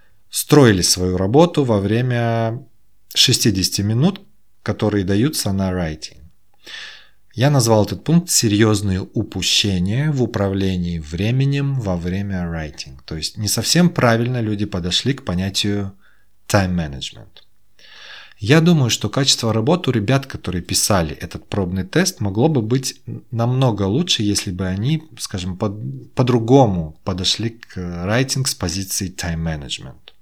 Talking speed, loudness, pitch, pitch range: 125 wpm, -18 LUFS, 105 Hz, 95-130 Hz